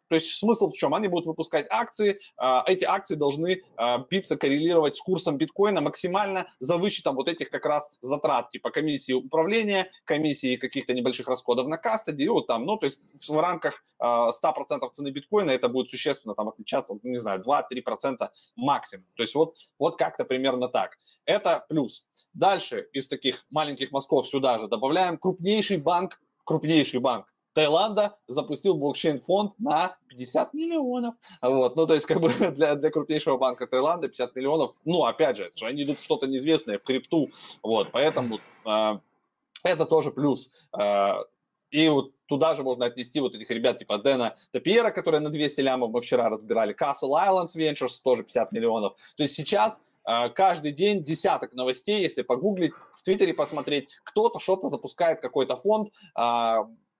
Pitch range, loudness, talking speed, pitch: 130-185 Hz, -26 LUFS, 165 wpm, 150 Hz